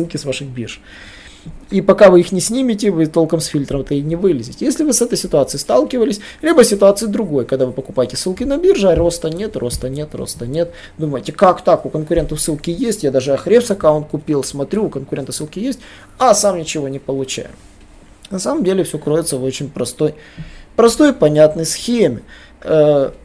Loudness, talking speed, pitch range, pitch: -15 LUFS, 190 wpm, 140-200 Hz, 160 Hz